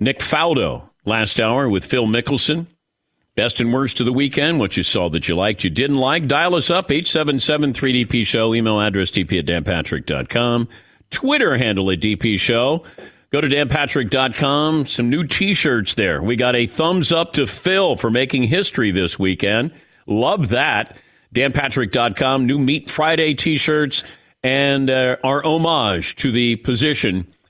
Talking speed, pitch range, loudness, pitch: 155 wpm, 115-150 Hz, -18 LUFS, 130 Hz